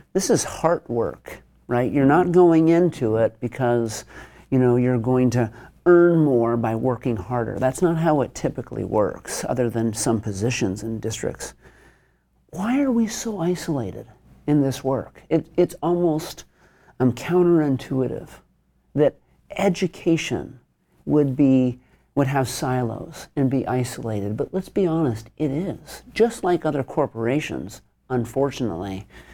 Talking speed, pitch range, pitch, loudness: 135 wpm, 120-165 Hz, 130 Hz, -22 LUFS